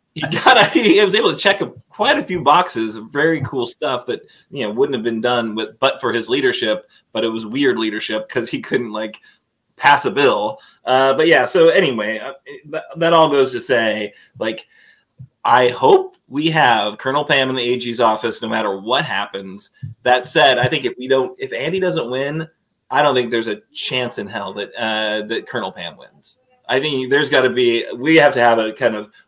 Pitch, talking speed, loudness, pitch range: 130 Hz, 215 wpm, -17 LUFS, 115-165 Hz